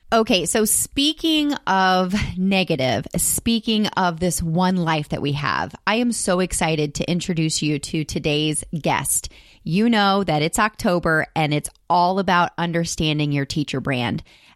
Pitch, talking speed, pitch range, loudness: 175 Hz, 150 wpm, 155-195 Hz, -20 LUFS